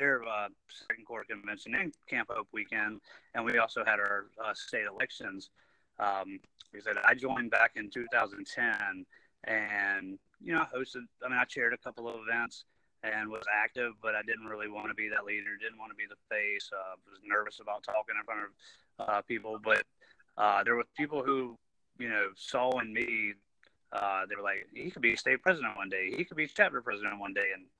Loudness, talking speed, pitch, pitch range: -33 LUFS, 210 wpm, 115 Hz, 105-145 Hz